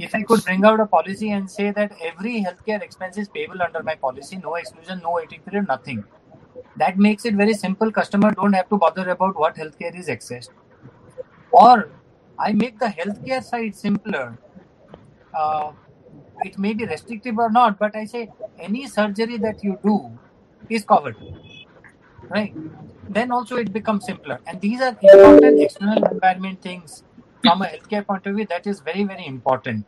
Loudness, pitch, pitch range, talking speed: -19 LUFS, 200 Hz, 165-220 Hz, 175 wpm